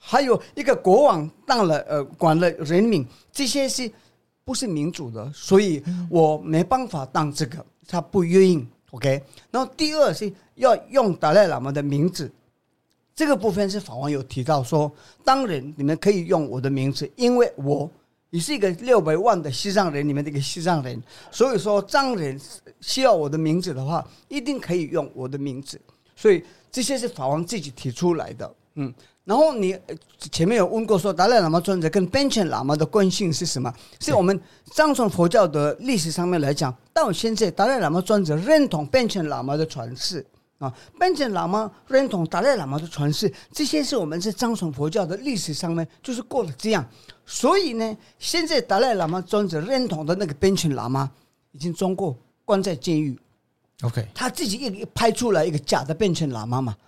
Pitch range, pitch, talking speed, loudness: 145-215 Hz, 175 Hz, 285 characters per minute, -22 LUFS